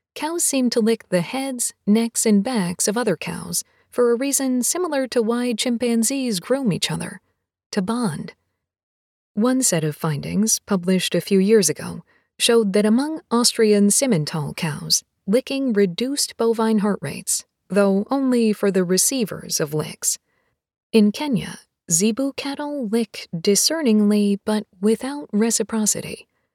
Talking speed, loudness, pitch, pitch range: 135 wpm, -20 LUFS, 220 Hz, 195-245 Hz